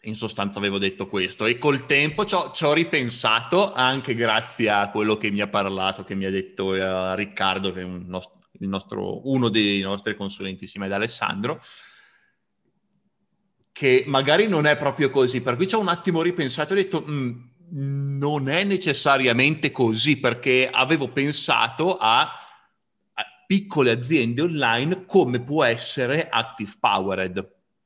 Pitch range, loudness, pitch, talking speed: 100-155 Hz, -22 LUFS, 130 Hz, 155 wpm